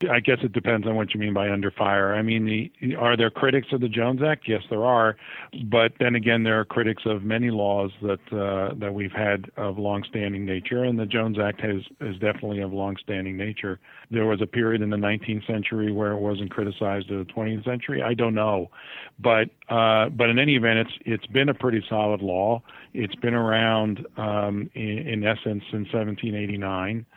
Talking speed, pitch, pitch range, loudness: 205 wpm, 110 Hz, 100-115 Hz, -24 LUFS